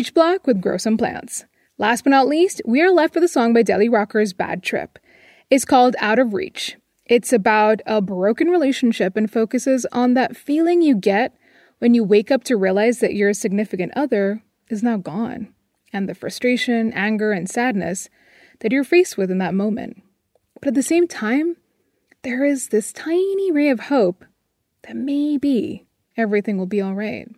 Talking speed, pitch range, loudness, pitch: 175 wpm, 210-275 Hz, -19 LUFS, 235 Hz